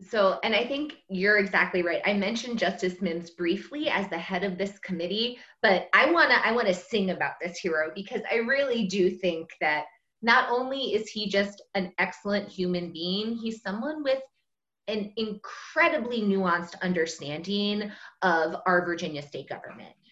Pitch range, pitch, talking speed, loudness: 180-220 Hz, 195 Hz, 165 wpm, -27 LUFS